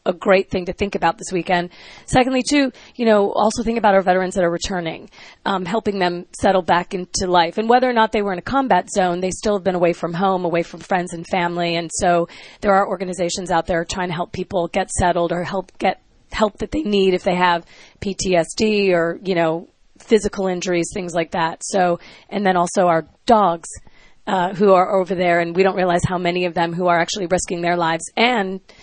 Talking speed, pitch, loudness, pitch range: 225 wpm, 185 Hz, -19 LUFS, 175-195 Hz